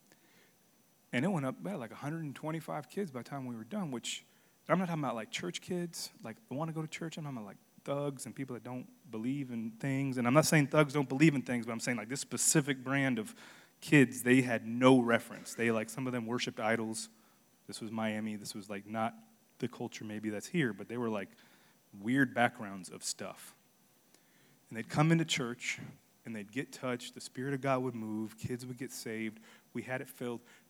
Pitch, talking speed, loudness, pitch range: 125 Hz, 225 wpm, -34 LUFS, 115-145 Hz